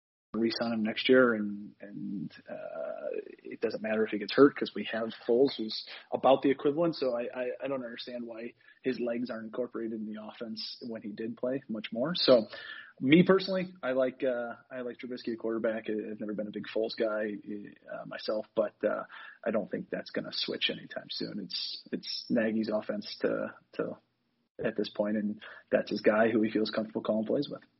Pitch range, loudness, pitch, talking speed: 110-130 Hz, -31 LUFS, 115 Hz, 200 wpm